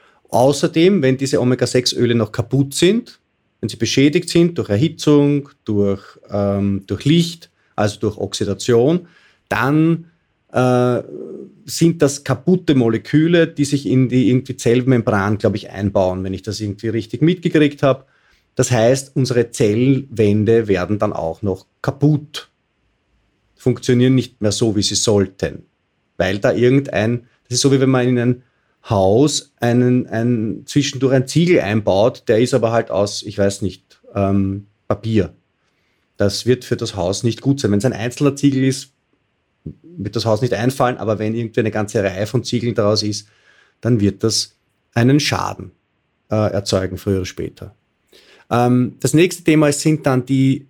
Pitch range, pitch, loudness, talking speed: 105-135 Hz, 120 Hz, -17 LUFS, 155 wpm